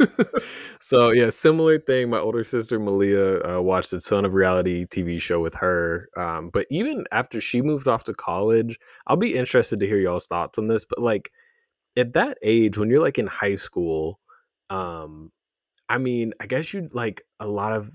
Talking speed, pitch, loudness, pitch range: 190 wpm, 110 Hz, -22 LUFS, 95-125 Hz